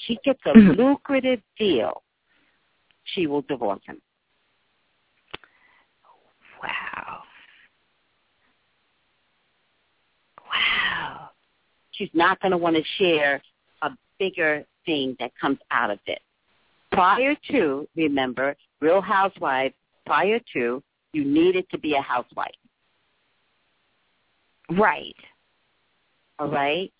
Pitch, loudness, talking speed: 190 Hz, -23 LUFS, 95 wpm